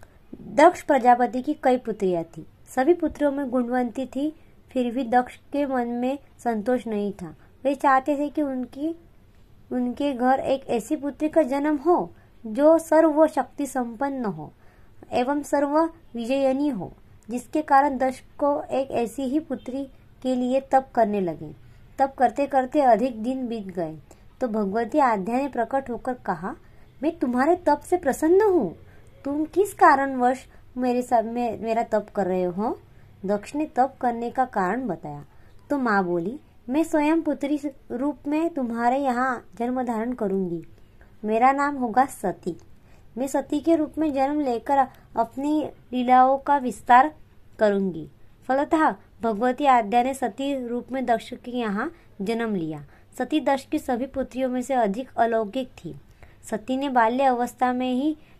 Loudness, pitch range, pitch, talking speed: -24 LUFS, 230-285 Hz, 255 Hz, 155 wpm